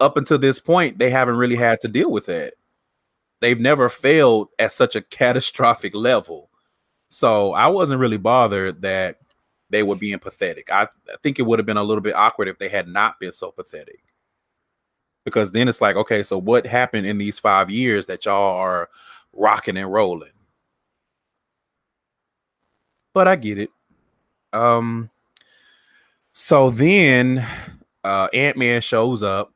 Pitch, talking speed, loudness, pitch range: 120 Hz, 155 wpm, -18 LUFS, 105-145 Hz